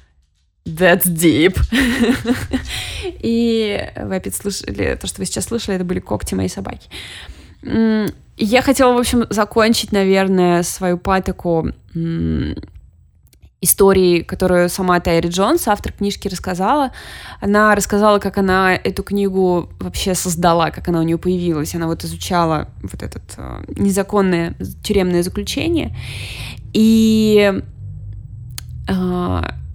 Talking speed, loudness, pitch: 110 wpm, -17 LUFS, 185 Hz